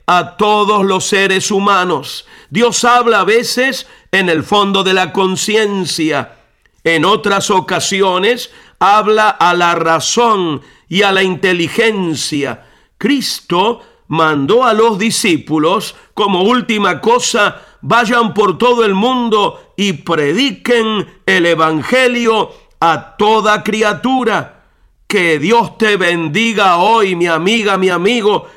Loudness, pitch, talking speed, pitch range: -12 LUFS, 200 Hz, 115 wpm, 175-225 Hz